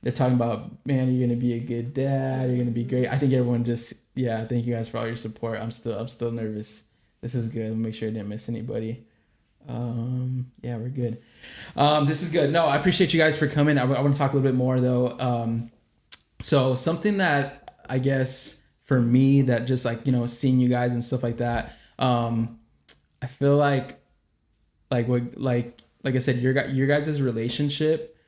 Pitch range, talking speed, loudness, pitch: 115-135 Hz, 215 wpm, -25 LUFS, 125 Hz